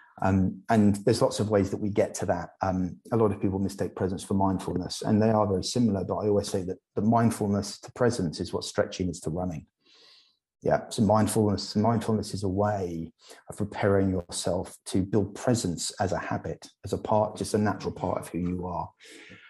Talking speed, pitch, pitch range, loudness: 205 wpm, 100 Hz, 95-110 Hz, -28 LUFS